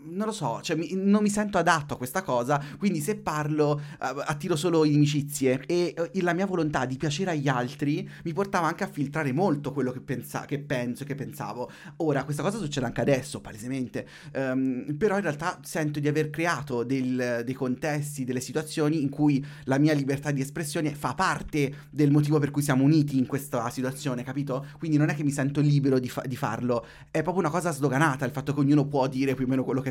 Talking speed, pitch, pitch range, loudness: 210 wpm, 145 Hz, 130-160 Hz, -27 LUFS